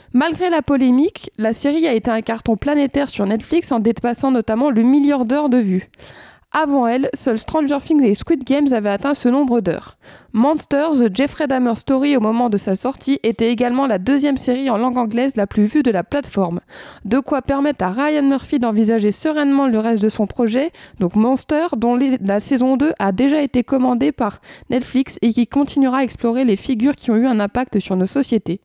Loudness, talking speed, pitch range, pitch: -17 LUFS, 205 wpm, 225-280 Hz, 255 Hz